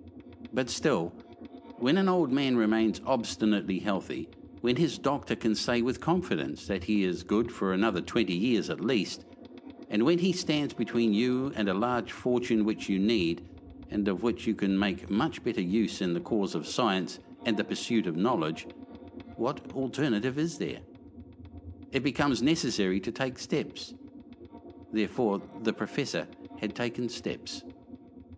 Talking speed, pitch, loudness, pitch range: 155 wpm, 115 Hz, -29 LUFS, 100-135 Hz